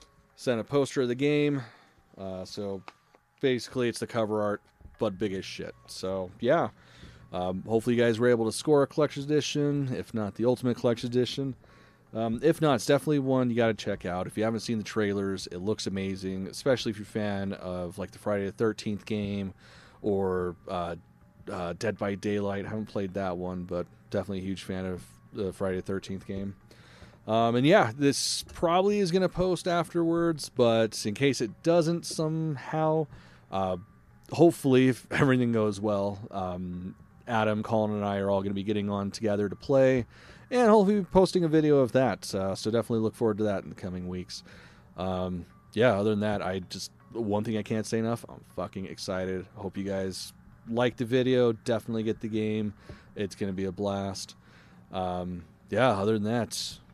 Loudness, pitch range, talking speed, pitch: -29 LUFS, 95-125 Hz, 190 wpm, 110 Hz